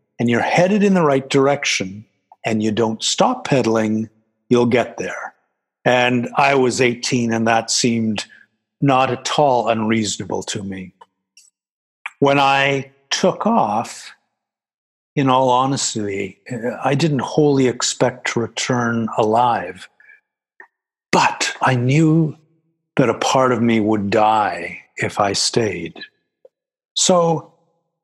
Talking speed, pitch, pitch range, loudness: 120 wpm, 130 Hz, 115-155 Hz, -17 LUFS